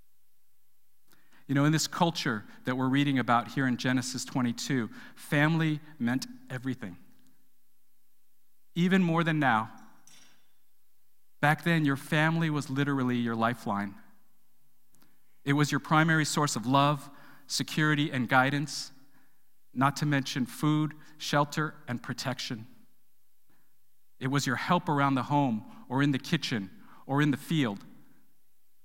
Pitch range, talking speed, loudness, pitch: 130-155 Hz, 125 wpm, -29 LUFS, 140 Hz